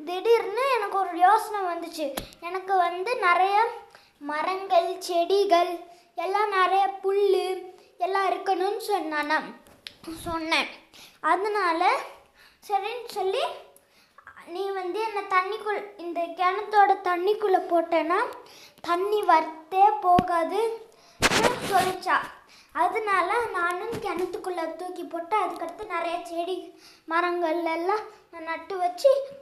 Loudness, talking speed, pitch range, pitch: -25 LUFS, 95 wpm, 340-405 Hz, 365 Hz